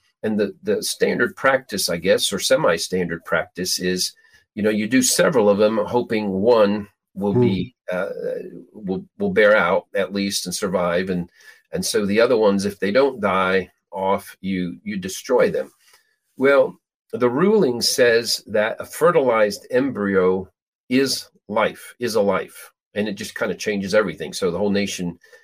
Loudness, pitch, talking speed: -20 LUFS, 105 Hz, 165 wpm